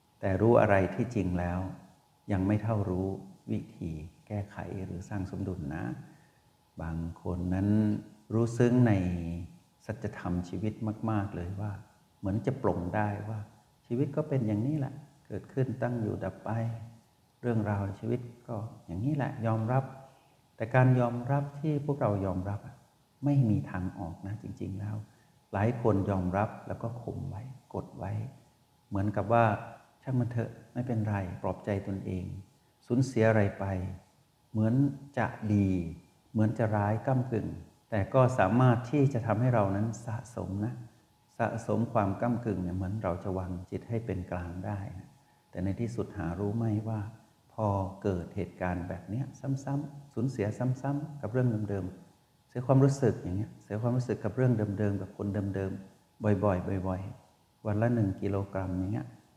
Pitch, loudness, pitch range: 105 Hz, -32 LUFS, 95-120 Hz